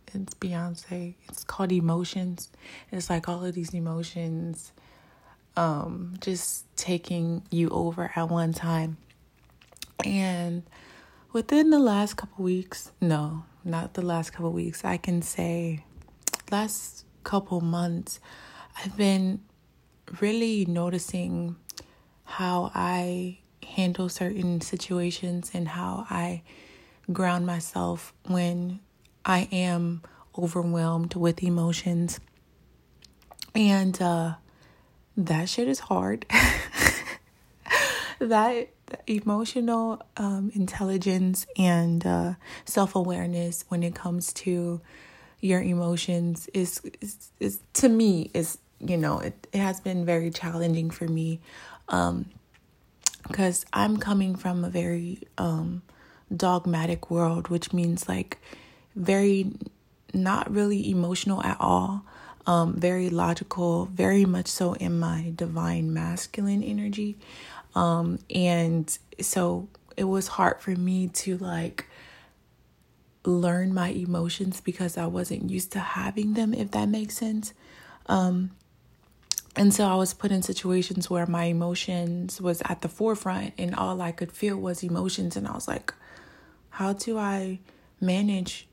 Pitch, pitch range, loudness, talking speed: 180 Hz, 170-190 Hz, -27 LUFS, 120 wpm